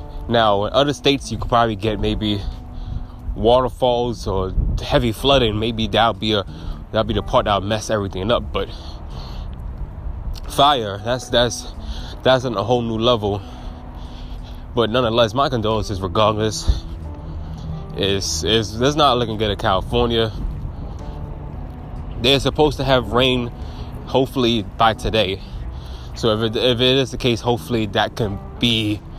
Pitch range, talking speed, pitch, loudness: 80-120 Hz, 140 wpm, 110 Hz, -19 LUFS